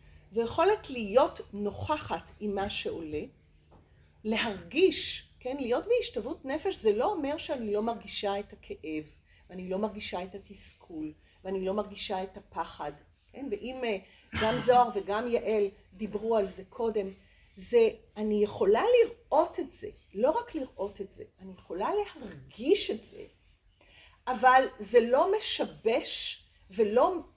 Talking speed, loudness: 135 wpm, -30 LUFS